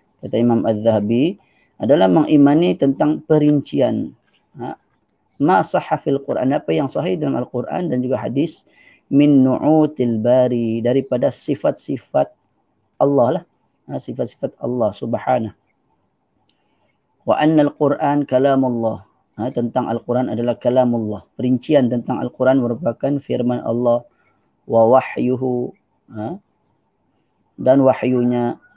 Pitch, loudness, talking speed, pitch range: 125 Hz, -18 LUFS, 110 wpm, 120-140 Hz